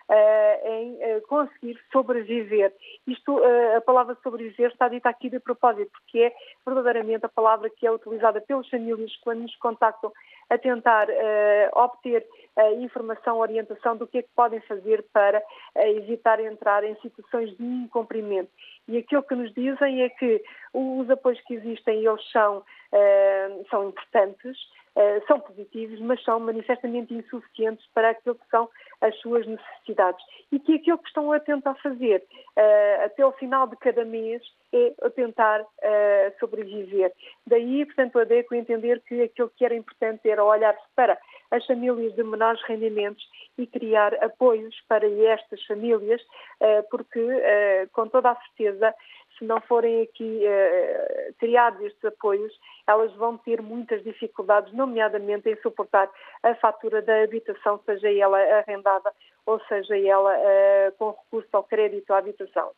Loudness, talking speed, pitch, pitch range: -23 LUFS, 155 wpm, 230 Hz, 215-255 Hz